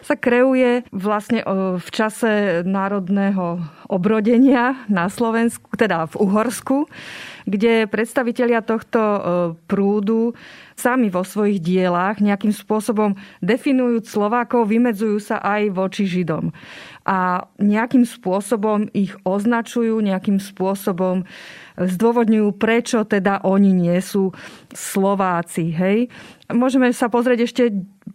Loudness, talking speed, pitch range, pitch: -19 LUFS, 100 wpm, 195-235 Hz, 210 Hz